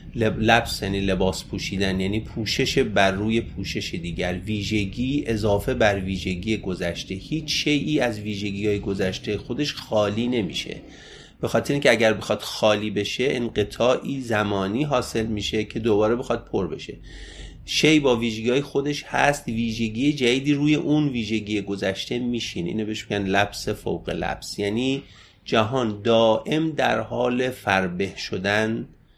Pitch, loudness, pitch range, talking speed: 110 Hz, -23 LUFS, 100-125 Hz, 140 wpm